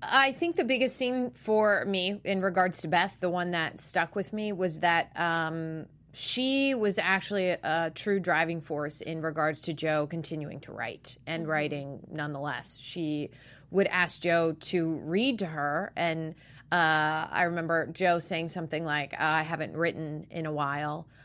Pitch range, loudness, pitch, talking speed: 155-185 Hz, -29 LUFS, 165 Hz, 170 wpm